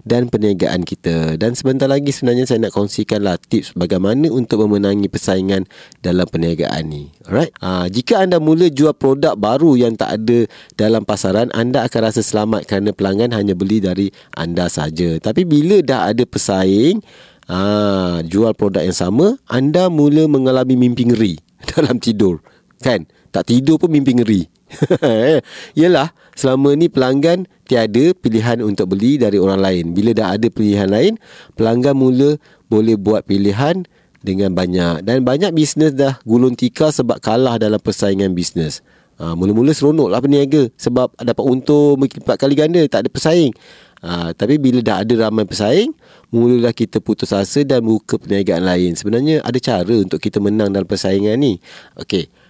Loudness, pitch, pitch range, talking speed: -15 LUFS, 115 Hz, 100-135 Hz, 160 wpm